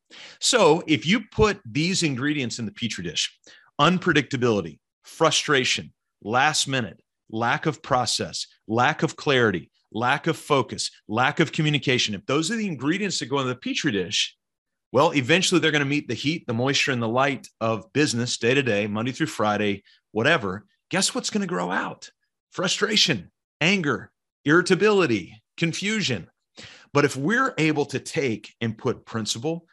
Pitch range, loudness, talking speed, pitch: 120-170 Hz, -23 LUFS, 155 wpm, 145 Hz